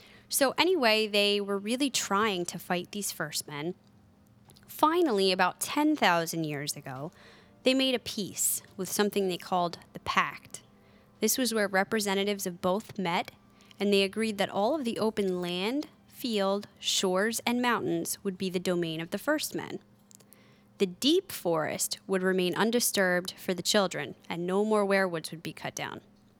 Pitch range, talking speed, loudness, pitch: 180-225 Hz, 160 wpm, -29 LUFS, 195 Hz